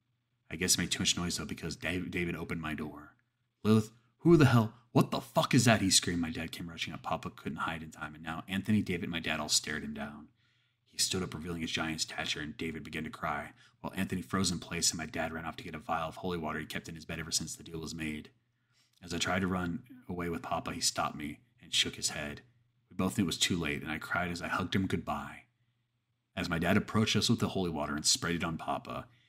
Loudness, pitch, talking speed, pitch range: -32 LUFS, 95 Hz, 265 wpm, 80-120 Hz